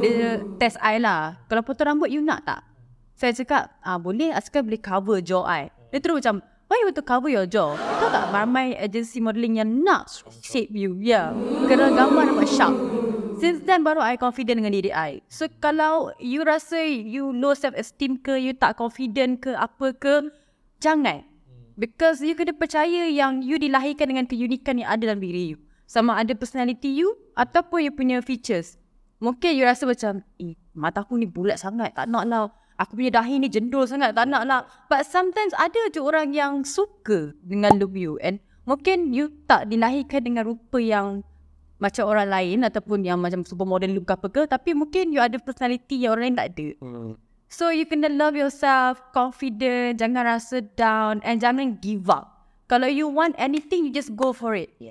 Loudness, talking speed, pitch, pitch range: -23 LUFS, 190 wpm, 245 Hz, 210-280 Hz